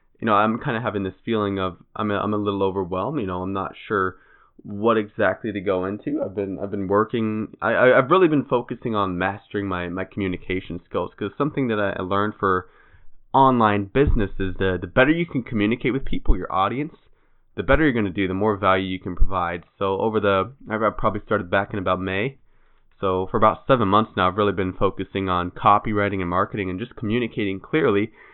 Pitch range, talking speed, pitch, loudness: 95-110 Hz, 210 wpm, 100 Hz, -22 LUFS